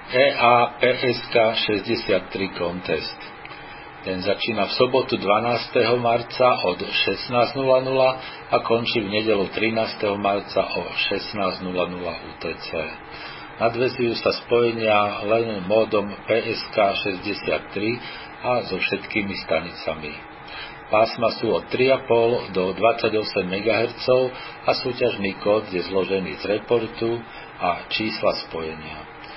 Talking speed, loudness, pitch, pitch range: 100 wpm, -22 LUFS, 110 Hz, 95-120 Hz